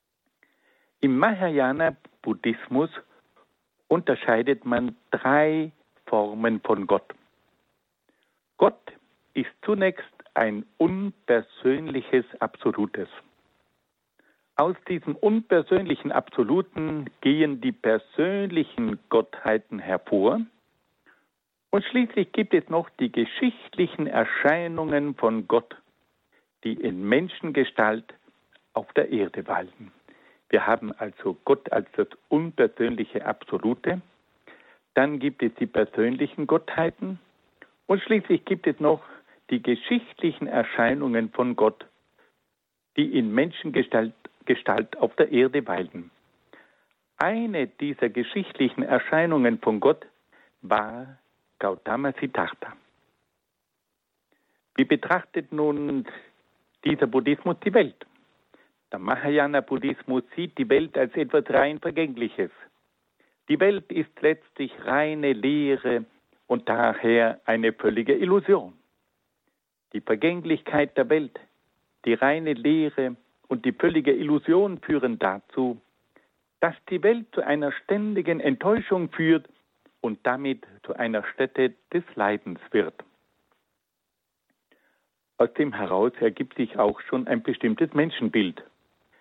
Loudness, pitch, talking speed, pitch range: -25 LUFS, 150 Hz, 100 wpm, 130-185 Hz